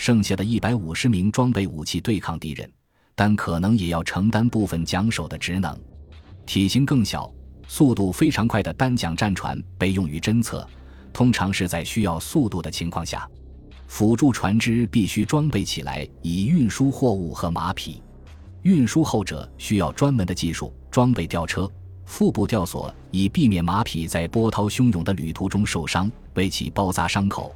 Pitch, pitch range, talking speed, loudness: 95 Hz, 80-110 Hz, 260 characters per minute, -22 LUFS